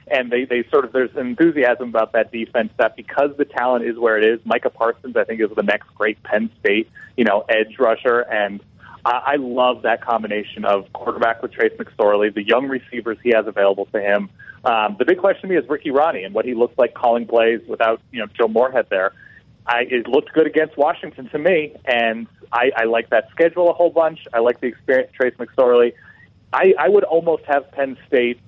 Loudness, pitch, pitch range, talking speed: -19 LUFS, 120 Hz, 115-145 Hz, 215 wpm